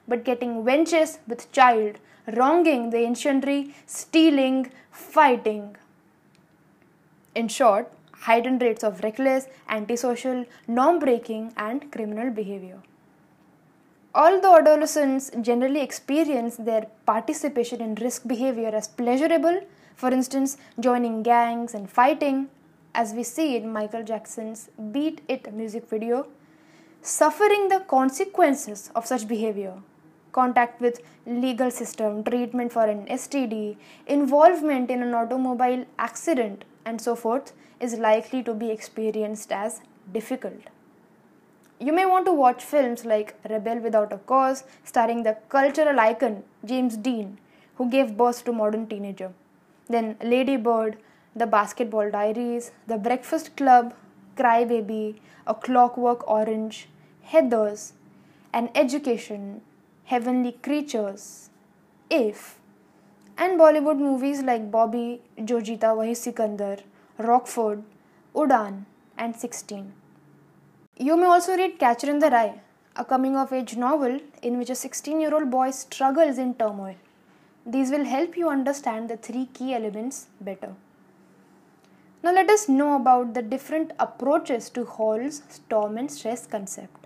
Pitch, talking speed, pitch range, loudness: 245 Hz, 120 wpm, 220-270 Hz, -23 LUFS